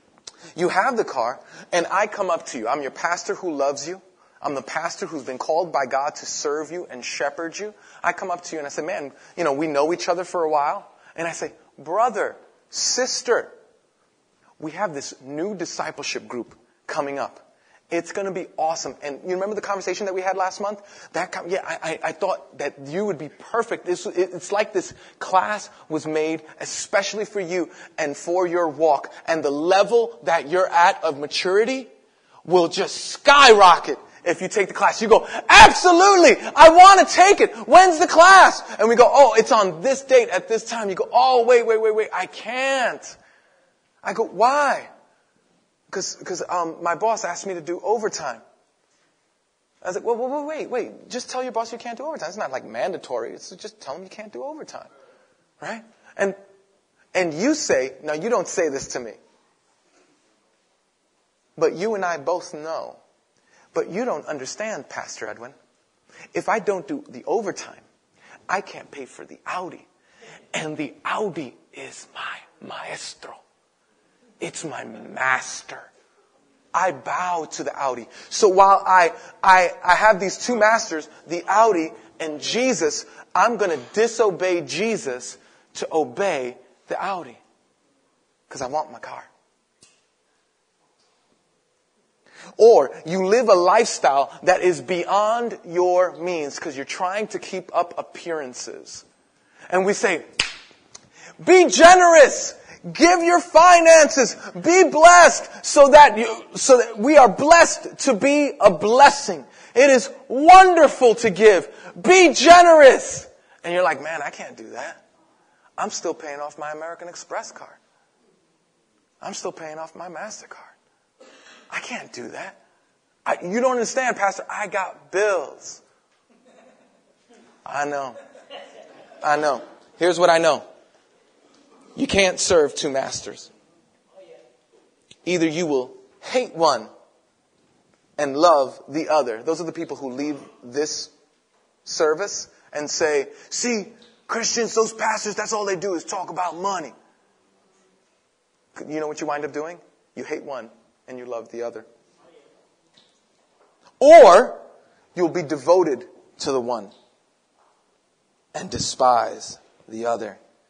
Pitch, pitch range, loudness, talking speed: 195 Hz, 165-260 Hz, -18 LUFS, 155 wpm